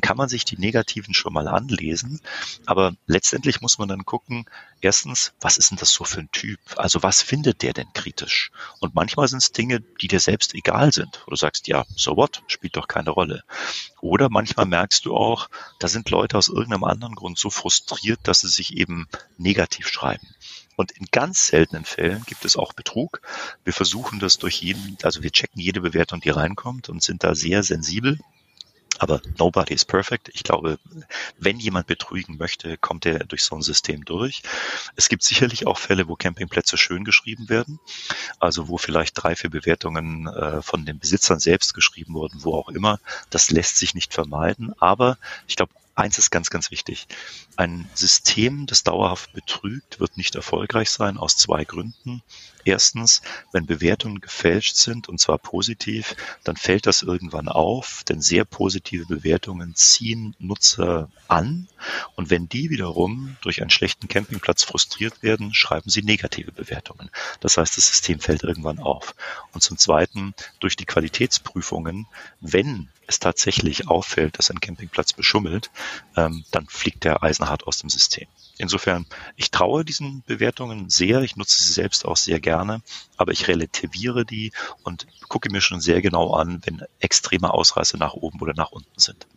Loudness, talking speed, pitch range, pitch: -20 LUFS, 175 wpm, 85-115 Hz, 95 Hz